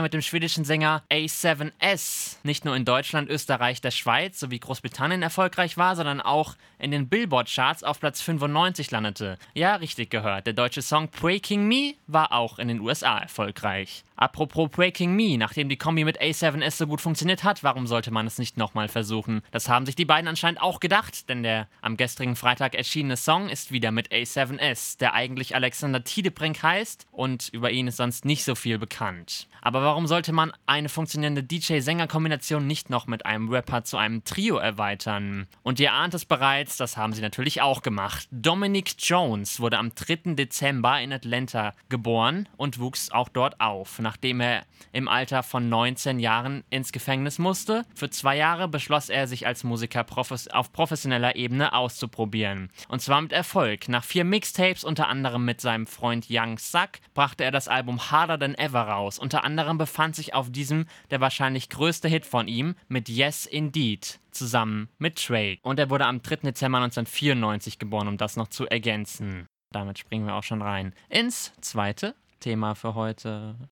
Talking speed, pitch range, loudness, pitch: 180 wpm, 115-155 Hz, -25 LUFS, 135 Hz